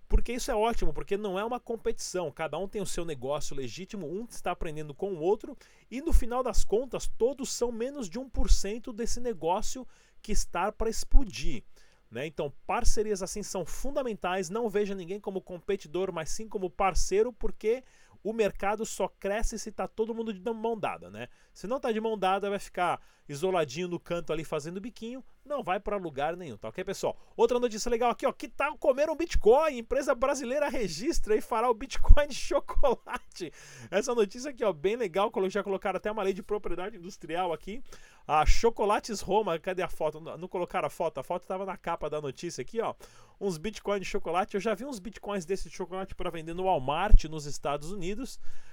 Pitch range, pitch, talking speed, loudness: 180-235 Hz, 205 Hz, 200 wpm, -32 LUFS